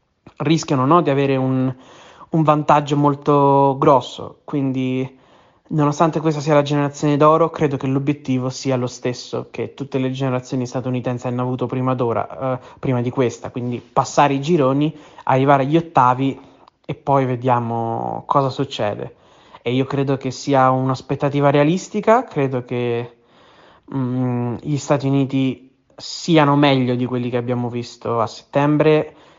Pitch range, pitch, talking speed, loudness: 125-145 Hz, 135 Hz, 140 wpm, -19 LUFS